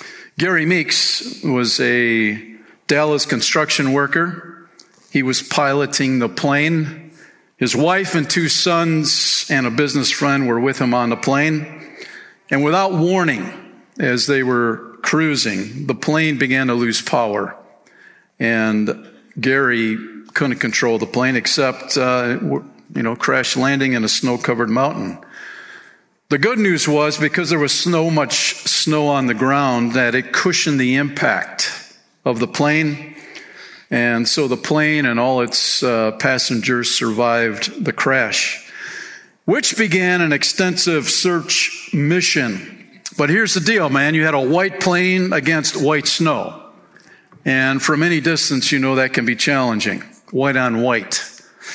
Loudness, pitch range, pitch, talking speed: -17 LUFS, 125-170 Hz, 145 Hz, 140 wpm